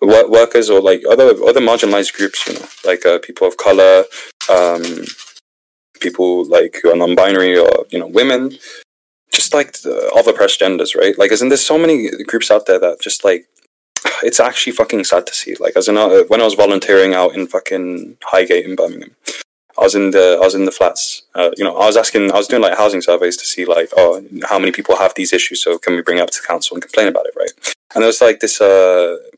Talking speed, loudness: 230 wpm, -12 LUFS